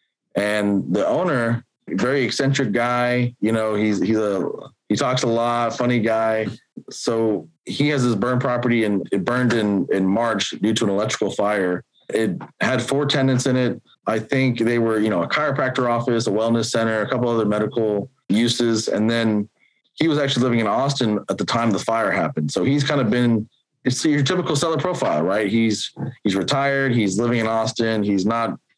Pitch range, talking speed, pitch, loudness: 110-130 Hz, 190 wpm, 115 Hz, -20 LUFS